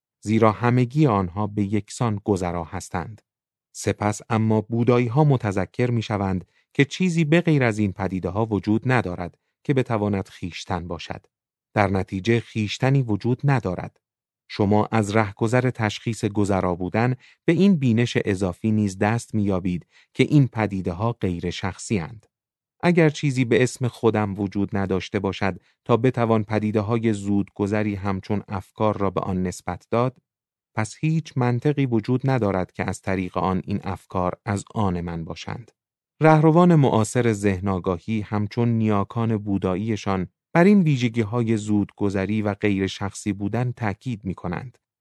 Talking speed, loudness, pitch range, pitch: 145 wpm, -23 LUFS, 100-120 Hz, 110 Hz